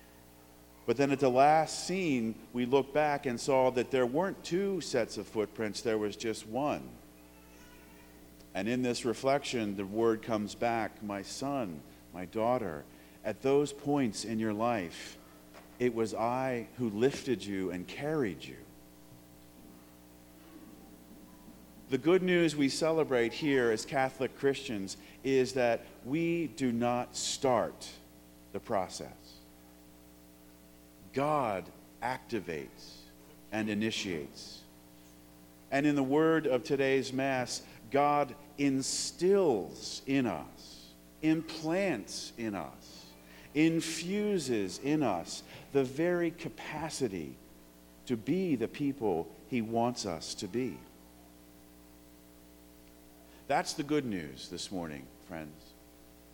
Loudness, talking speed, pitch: -32 LUFS, 115 wpm, 105 Hz